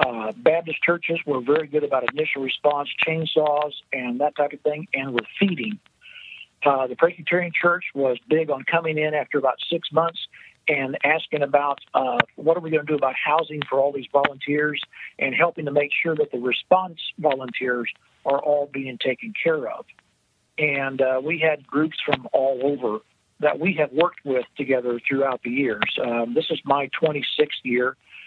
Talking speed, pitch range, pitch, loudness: 180 wpm, 135-160 Hz, 145 Hz, -23 LUFS